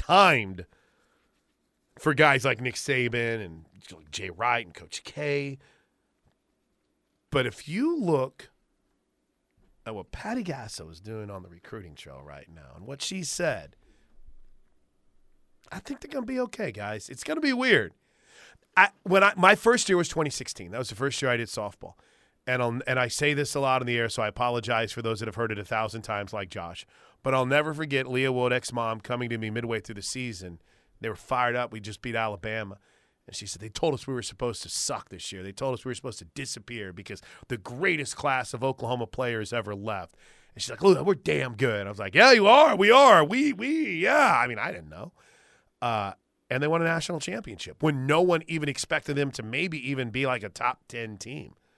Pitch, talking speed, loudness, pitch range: 125 Hz, 210 wpm, -25 LUFS, 110-145 Hz